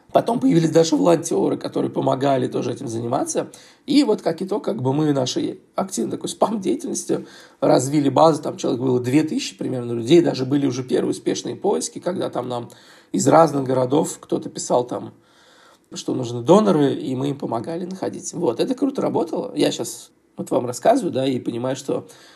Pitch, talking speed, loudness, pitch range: 155 Hz, 175 wpm, -21 LUFS, 130-175 Hz